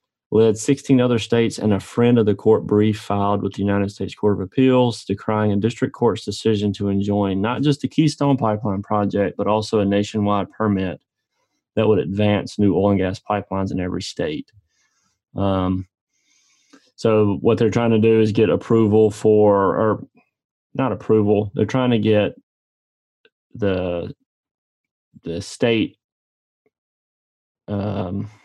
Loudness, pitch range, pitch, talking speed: -19 LUFS, 100-110 Hz, 105 Hz, 150 wpm